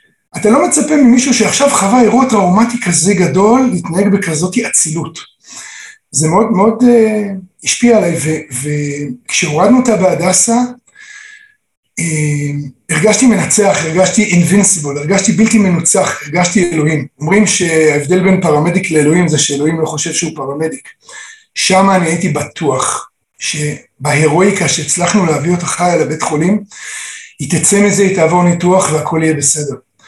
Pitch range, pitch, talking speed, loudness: 155-215 Hz, 180 Hz, 125 wpm, -11 LUFS